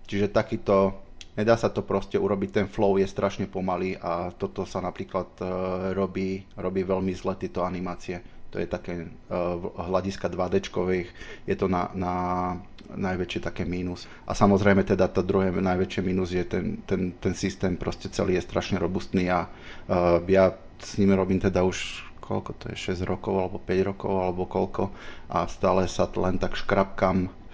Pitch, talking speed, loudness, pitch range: 95 Hz, 170 wpm, -27 LUFS, 90-95 Hz